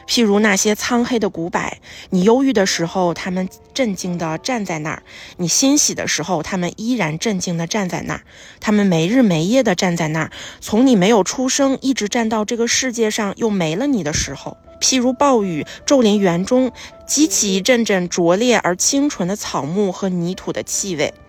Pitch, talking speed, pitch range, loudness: 205 Hz, 285 characters per minute, 175-240 Hz, -17 LUFS